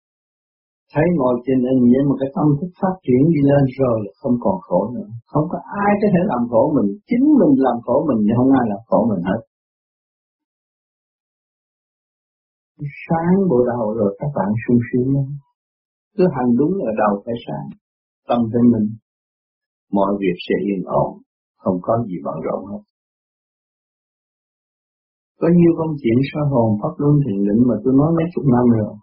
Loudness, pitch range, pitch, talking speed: -18 LUFS, 115-155 Hz, 130 Hz, 175 wpm